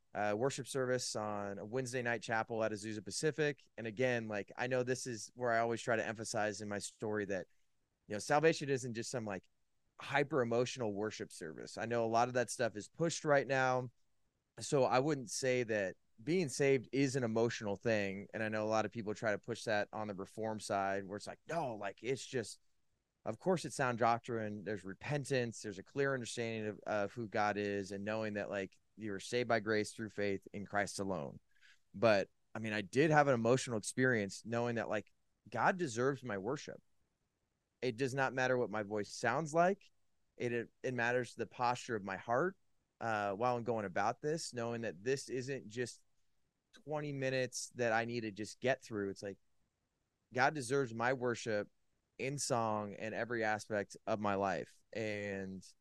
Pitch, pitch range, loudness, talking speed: 115 Hz, 105-130 Hz, -38 LUFS, 195 wpm